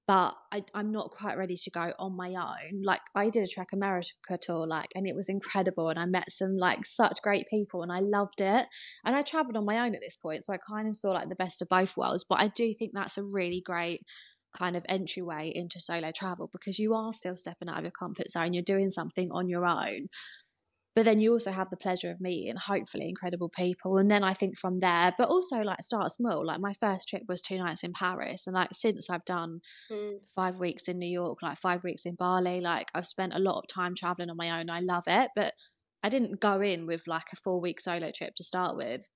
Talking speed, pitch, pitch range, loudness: 245 wpm, 185 Hz, 175-200 Hz, -31 LUFS